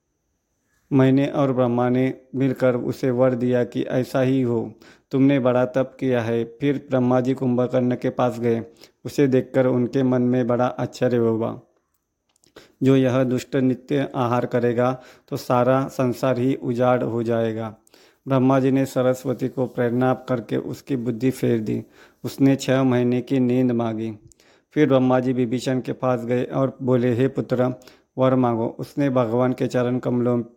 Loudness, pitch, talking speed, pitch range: -21 LUFS, 125 Hz, 155 wpm, 125-130 Hz